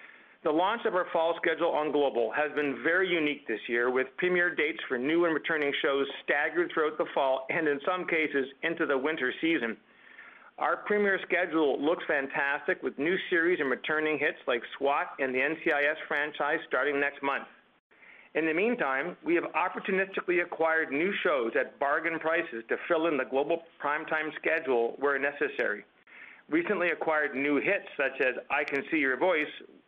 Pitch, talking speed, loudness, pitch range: 155 Hz, 175 wpm, -29 LUFS, 140-175 Hz